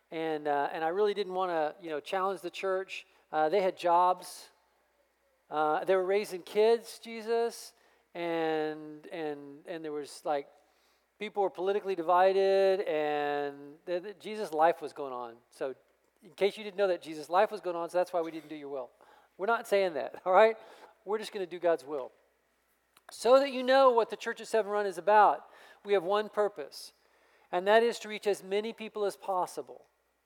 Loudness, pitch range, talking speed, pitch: -30 LUFS, 160-210 Hz, 200 wpm, 190 Hz